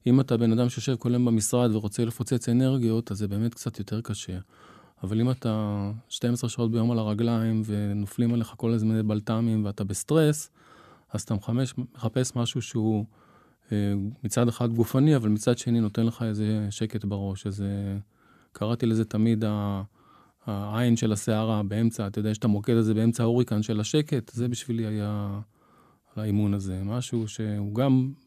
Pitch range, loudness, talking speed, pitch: 105-120 Hz, -27 LUFS, 160 wpm, 110 Hz